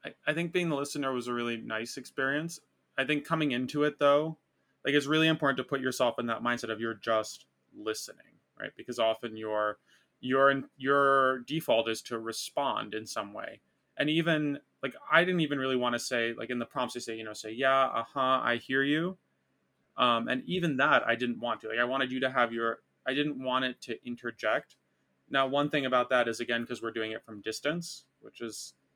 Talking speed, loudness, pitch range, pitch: 220 wpm, -30 LUFS, 115-140 Hz, 125 Hz